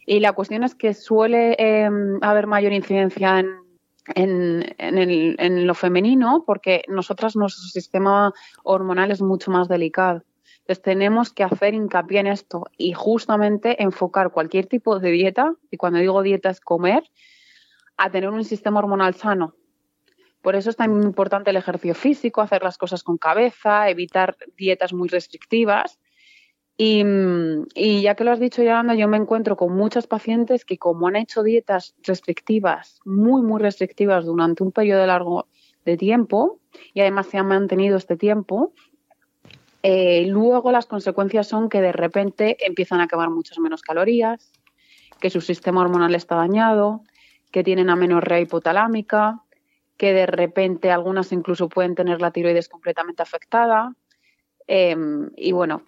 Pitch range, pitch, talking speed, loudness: 180-220 Hz, 195 Hz, 155 wpm, -20 LUFS